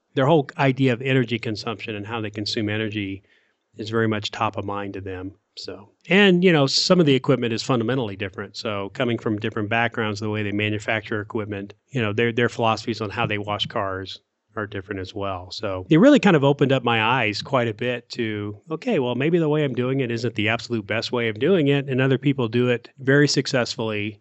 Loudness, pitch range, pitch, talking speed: -22 LUFS, 105-130 Hz, 115 Hz, 225 wpm